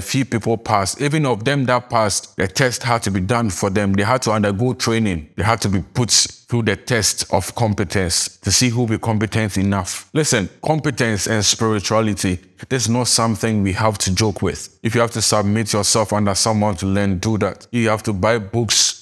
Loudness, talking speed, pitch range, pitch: -18 LUFS, 210 wpm, 100-120 Hz, 110 Hz